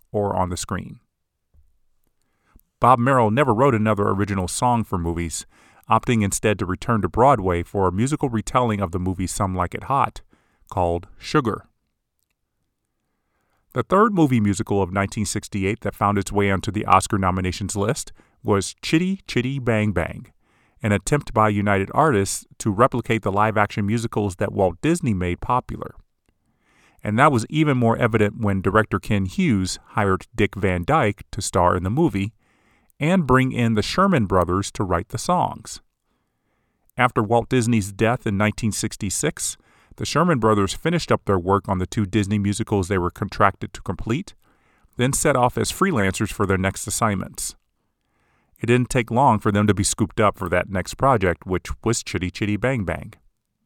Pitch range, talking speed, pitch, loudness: 95-120 Hz, 165 wpm, 105 Hz, -21 LUFS